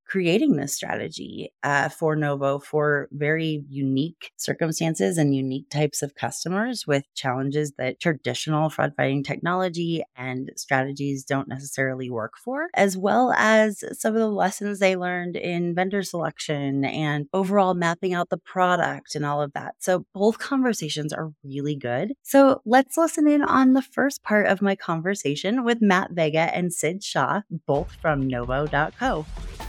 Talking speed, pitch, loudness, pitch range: 155 wpm, 160 Hz, -24 LUFS, 140-195 Hz